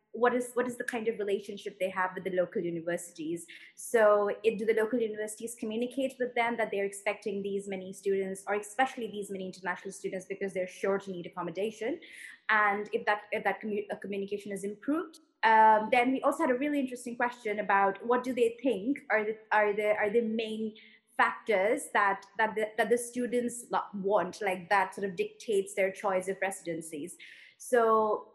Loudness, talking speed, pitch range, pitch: -31 LUFS, 190 wpm, 195-235 Hz, 215 Hz